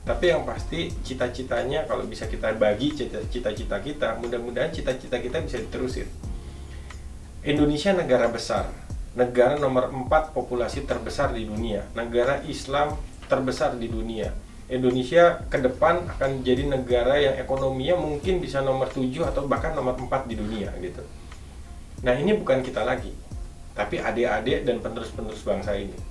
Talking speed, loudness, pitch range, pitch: 140 wpm, -25 LUFS, 100-135 Hz, 125 Hz